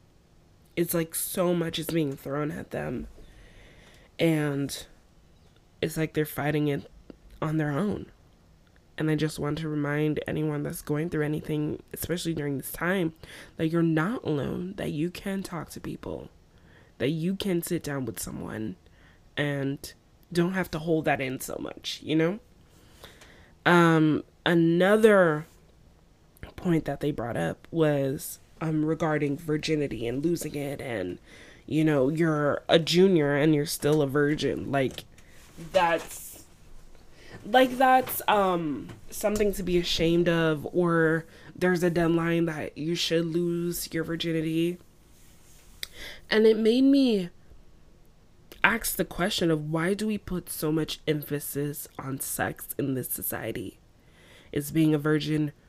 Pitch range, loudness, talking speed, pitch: 145-170 Hz, -27 LUFS, 140 wpm, 155 Hz